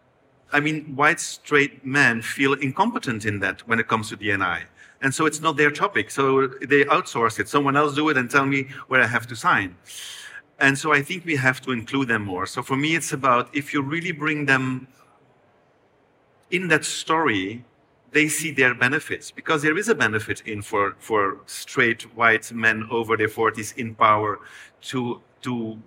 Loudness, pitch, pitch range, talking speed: -22 LUFS, 135 Hz, 115-150 Hz, 190 wpm